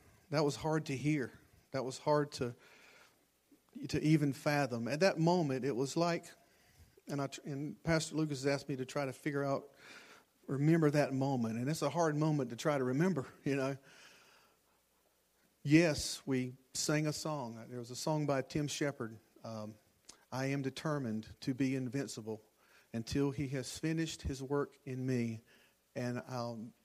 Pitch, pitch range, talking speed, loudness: 140 Hz, 125-150 Hz, 165 wpm, -36 LUFS